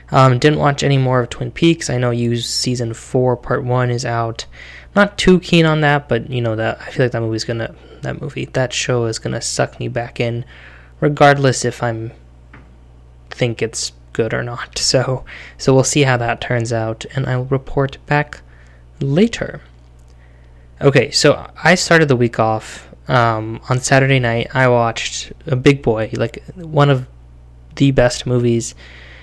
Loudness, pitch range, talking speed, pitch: -16 LUFS, 110-135 Hz, 175 wpm, 120 Hz